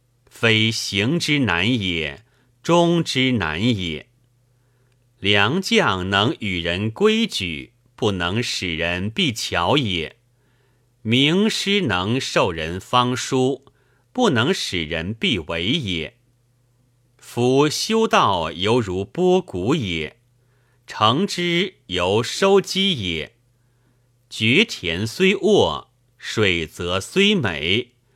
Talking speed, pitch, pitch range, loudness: 125 characters per minute, 120 Hz, 100-135 Hz, -20 LUFS